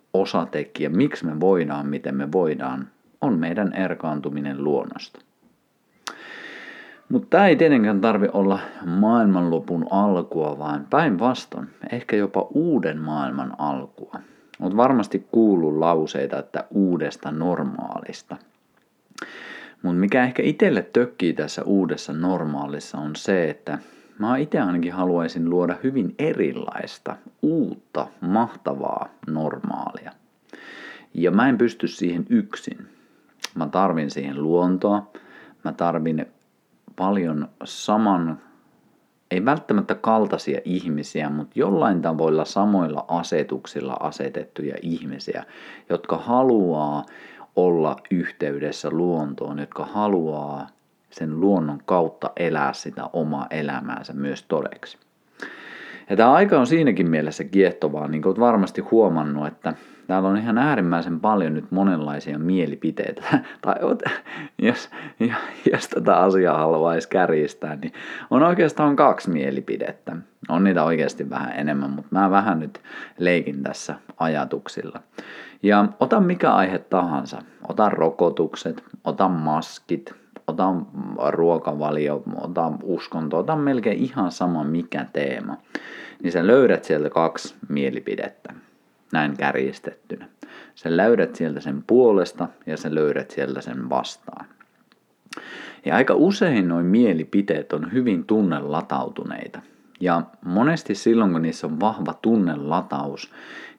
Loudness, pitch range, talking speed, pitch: -22 LUFS, 75-105 Hz, 115 wpm, 85 Hz